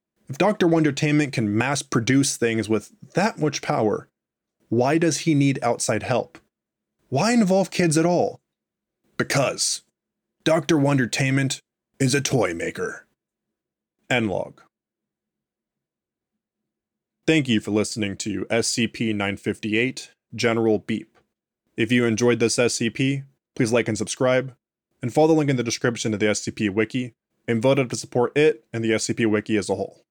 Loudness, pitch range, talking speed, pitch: -22 LUFS, 110-150 Hz, 145 wpm, 125 Hz